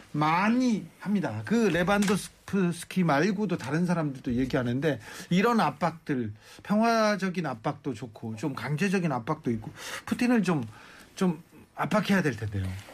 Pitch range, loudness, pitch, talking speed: 135-200 Hz, -28 LUFS, 165 Hz, 300 characters per minute